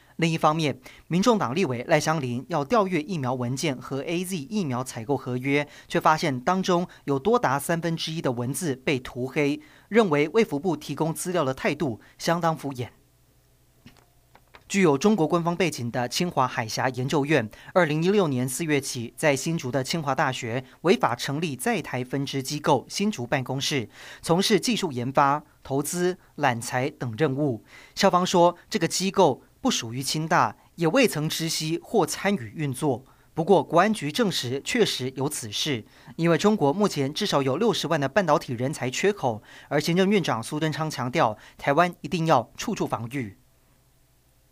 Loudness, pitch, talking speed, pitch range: -25 LUFS, 145 Hz, 265 characters per minute, 130-175 Hz